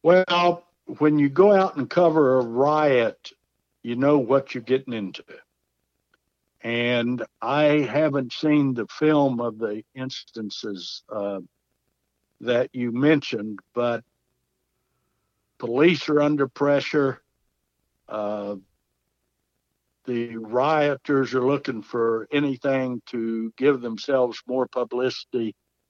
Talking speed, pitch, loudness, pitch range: 105 wpm, 130 Hz, -23 LUFS, 115-145 Hz